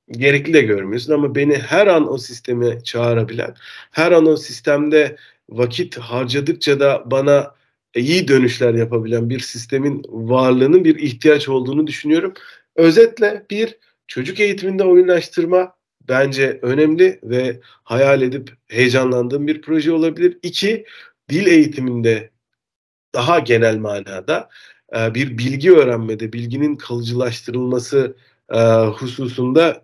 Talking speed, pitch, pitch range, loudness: 110 wpm, 135 Hz, 120-160 Hz, -16 LUFS